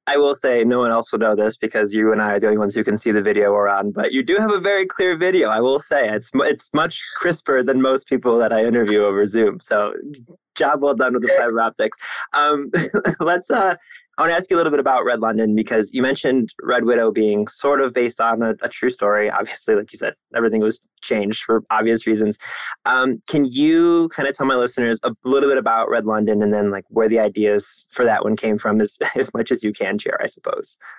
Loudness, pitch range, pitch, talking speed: -18 LUFS, 110-140 Hz, 115 Hz, 245 wpm